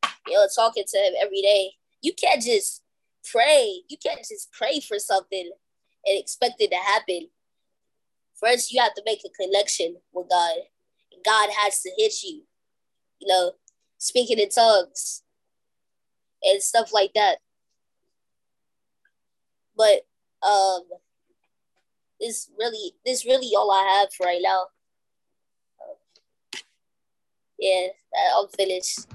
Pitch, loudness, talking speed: 220 Hz, -22 LUFS, 125 wpm